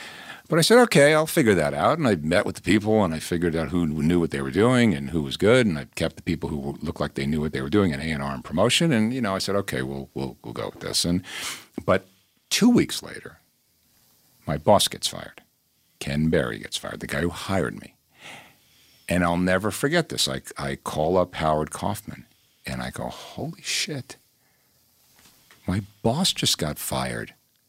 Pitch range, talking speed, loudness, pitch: 75-100 Hz, 210 wpm, -23 LUFS, 85 Hz